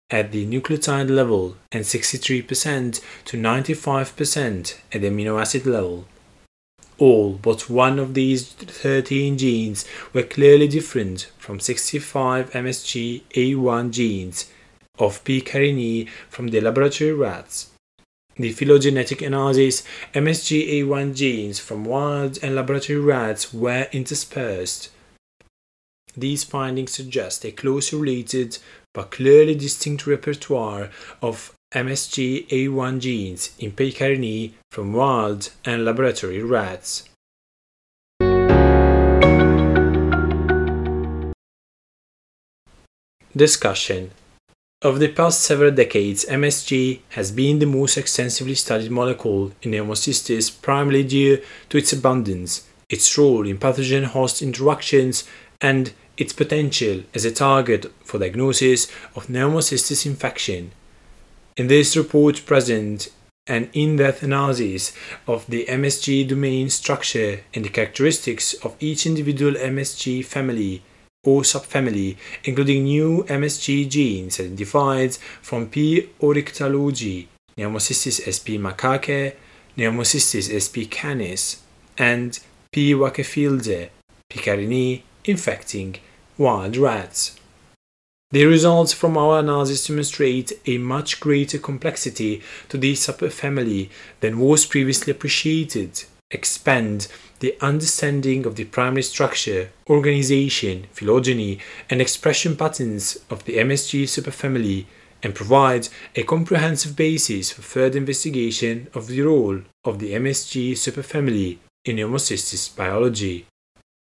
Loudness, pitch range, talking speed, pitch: -20 LUFS, 110-140 Hz, 105 wpm, 130 Hz